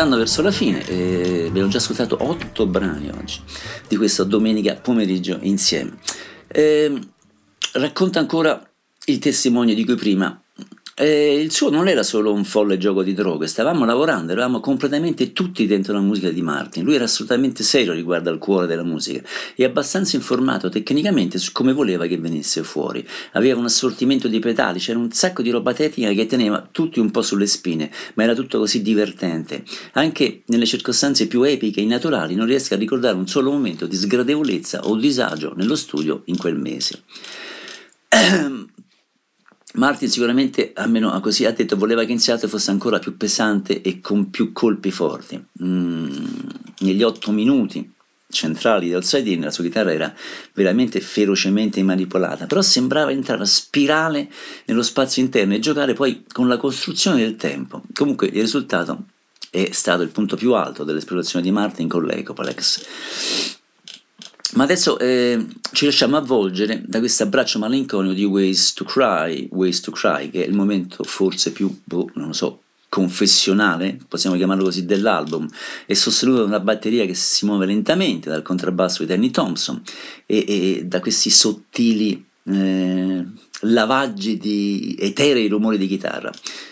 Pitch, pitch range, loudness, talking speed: 110 Hz, 95-130 Hz, -19 LUFS, 160 wpm